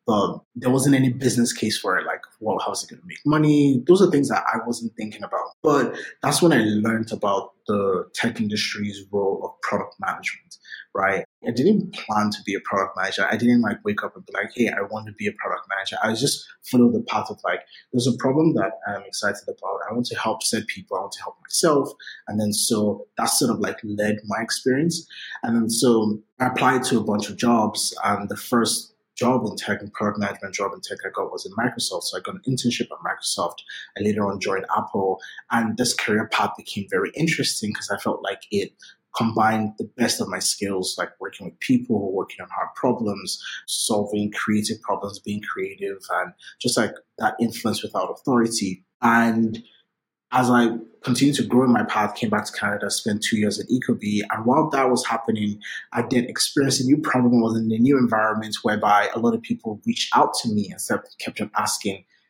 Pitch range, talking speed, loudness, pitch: 105-135 Hz, 215 wpm, -23 LUFS, 115 Hz